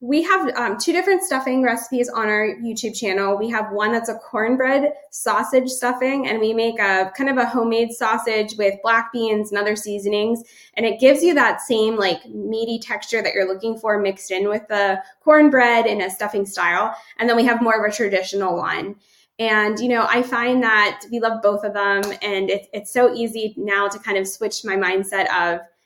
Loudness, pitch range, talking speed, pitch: -19 LUFS, 205-235 Hz, 205 wpm, 220 Hz